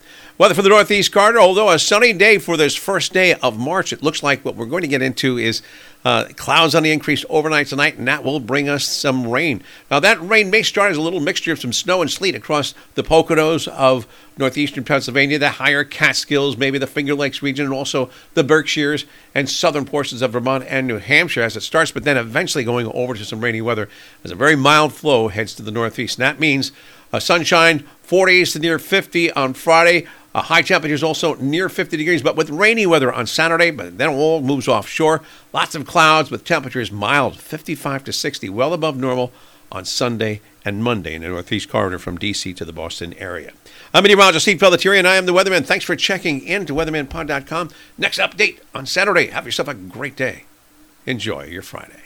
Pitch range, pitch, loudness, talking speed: 130-165 Hz, 145 Hz, -16 LUFS, 210 wpm